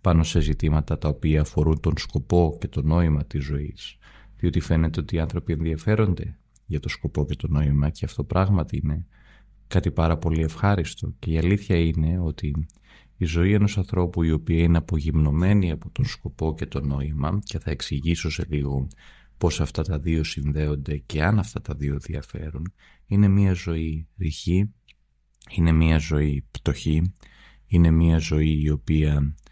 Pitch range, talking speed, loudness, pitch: 75-90 Hz, 165 wpm, -24 LUFS, 80 Hz